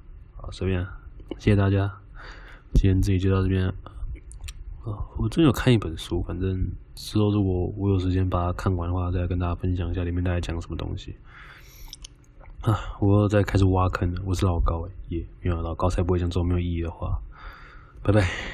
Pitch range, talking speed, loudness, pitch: 85-100 Hz, 310 characters per minute, -25 LUFS, 90 Hz